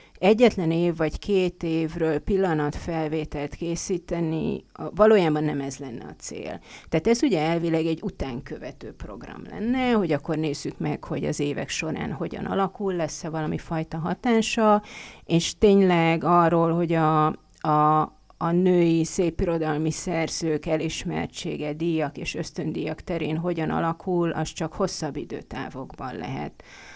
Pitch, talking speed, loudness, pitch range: 165 Hz, 125 wpm, -25 LUFS, 155-185 Hz